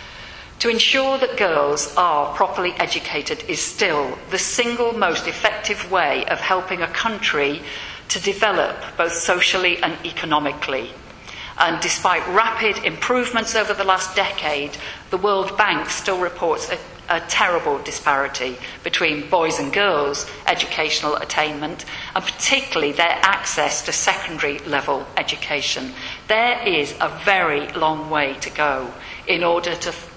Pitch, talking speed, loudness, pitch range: 180 Hz, 135 wpm, -19 LUFS, 155-215 Hz